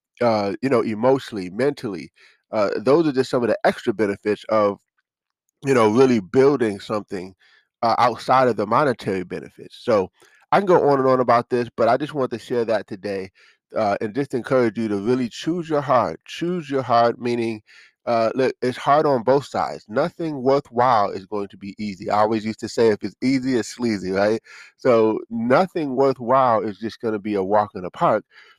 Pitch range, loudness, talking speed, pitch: 105-130 Hz, -21 LUFS, 200 wpm, 115 Hz